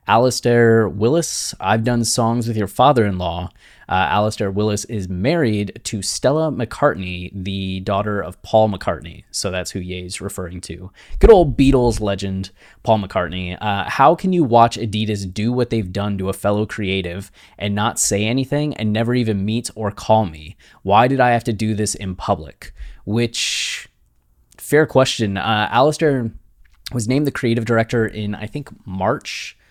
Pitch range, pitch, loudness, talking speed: 95-120 Hz, 105 Hz, -18 LUFS, 170 wpm